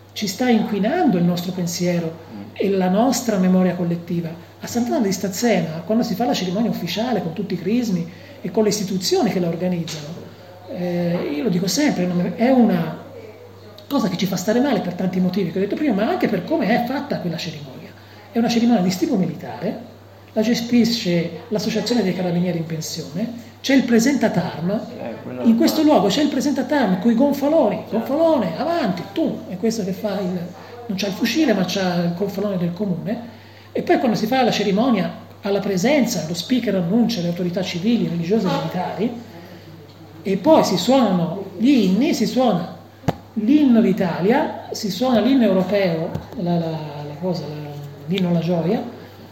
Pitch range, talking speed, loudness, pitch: 180-235 Hz, 175 wpm, -20 LUFS, 205 Hz